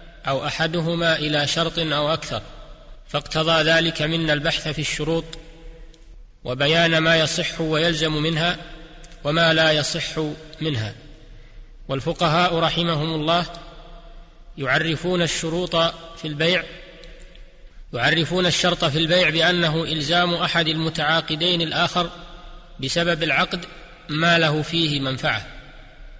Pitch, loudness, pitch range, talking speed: 165 Hz, -20 LUFS, 155-170 Hz, 100 wpm